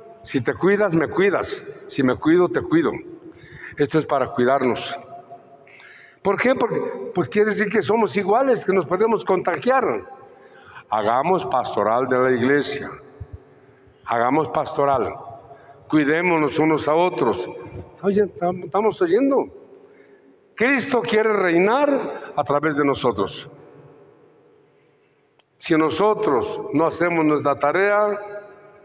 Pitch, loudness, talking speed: 200 Hz, -20 LUFS, 115 wpm